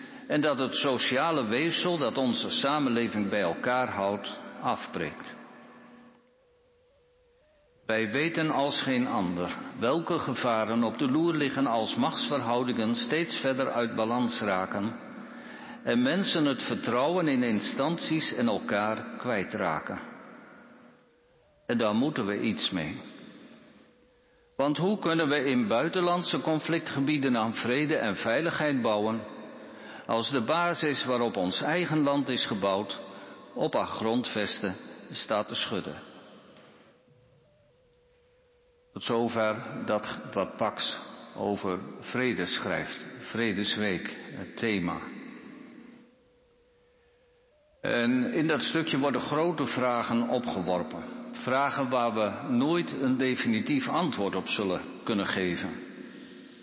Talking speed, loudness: 110 wpm, -29 LUFS